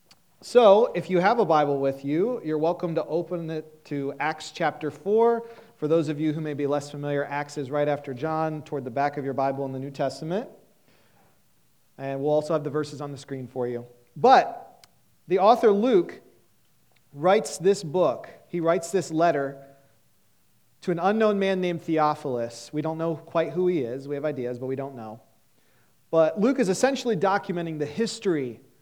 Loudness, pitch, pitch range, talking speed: -25 LUFS, 150 Hz, 140-175 Hz, 185 wpm